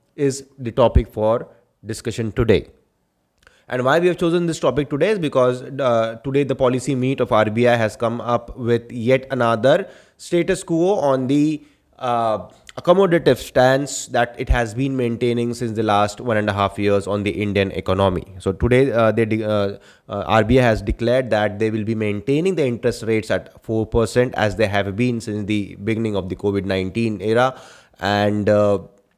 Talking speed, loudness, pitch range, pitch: 180 wpm, -19 LUFS, 105-130 Hz, 115 Hz